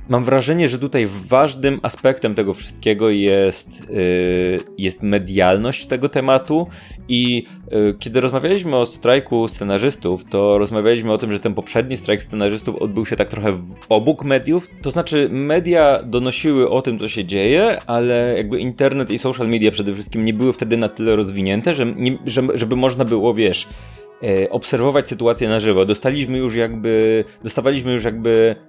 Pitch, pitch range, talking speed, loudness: 115 Hz, 105-130 Hz, 160 wpm, -18 LUFS